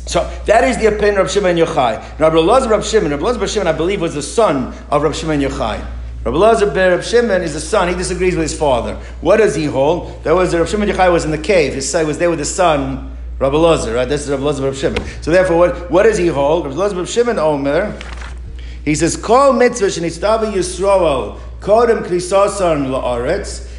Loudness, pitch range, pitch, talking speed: -15 LUFS, 145-200 Hz, 170 Hz, 210 wpm